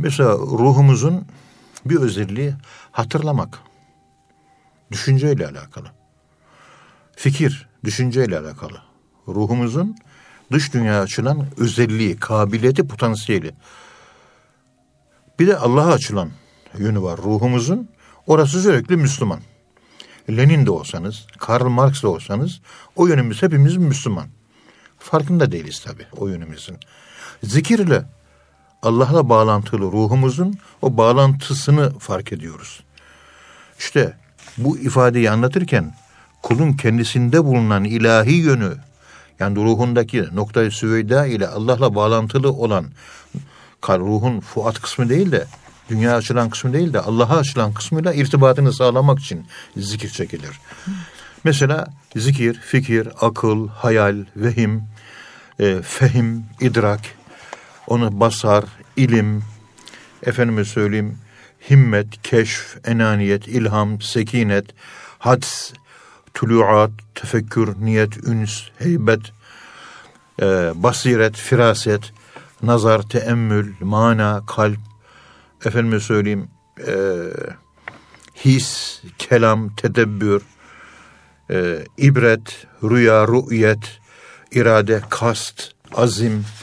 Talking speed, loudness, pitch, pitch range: 90 wpm, -17 LUFS, 115 Hz, 105-130 Hz